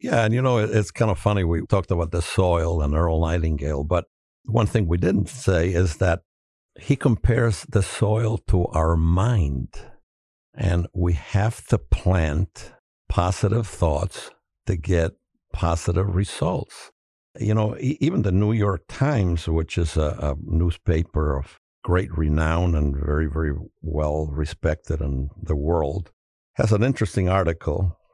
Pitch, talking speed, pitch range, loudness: 85 Hz, 145 wpm, 80-105 Hz, -23 LUFS